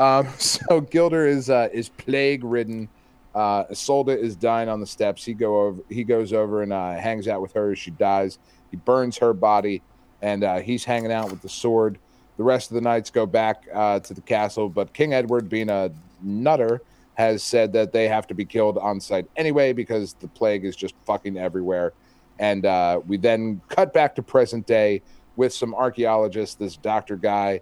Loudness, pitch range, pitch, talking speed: -22 LUFS, 100-120 Hz, 110 Hz, 200 wpm